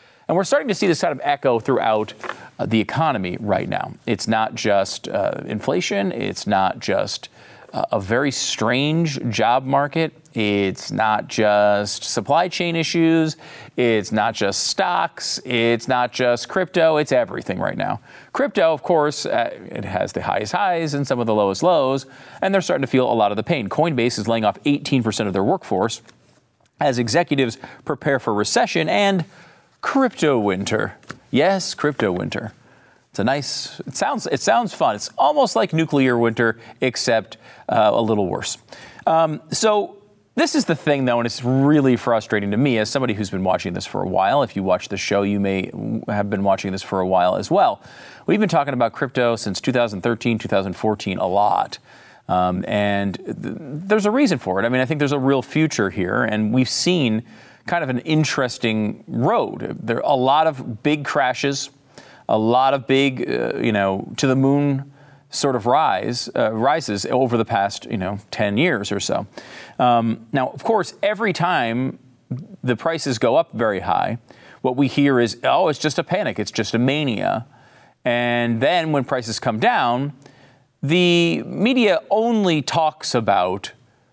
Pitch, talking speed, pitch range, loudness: 130 Hz, 180 wpm, 110-150 Hz, -20 LUFS